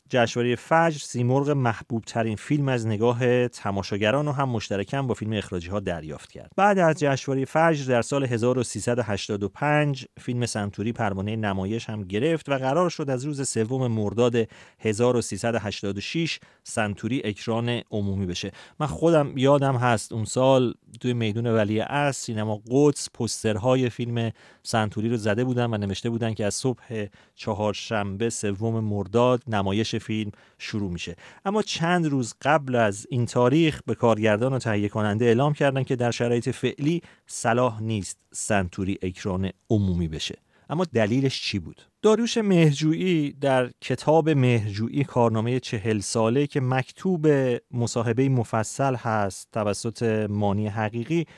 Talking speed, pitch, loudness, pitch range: 140 wpm, 120 Hz, -25 LUFS, 105-135 Hz